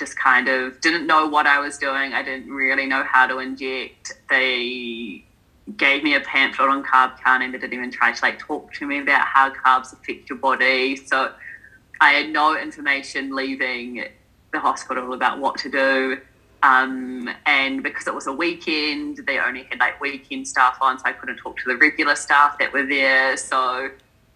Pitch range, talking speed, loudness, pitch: 130-145 Hz, 190 wpm, -19 LUFS, 135 Hz